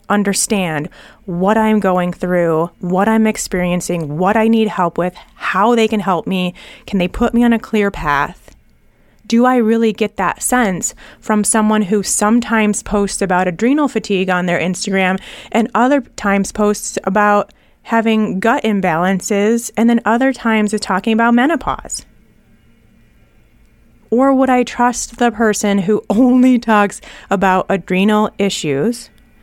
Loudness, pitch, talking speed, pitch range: -15 LUFS, 210 Hz, 145 wpm, 190-230 Hz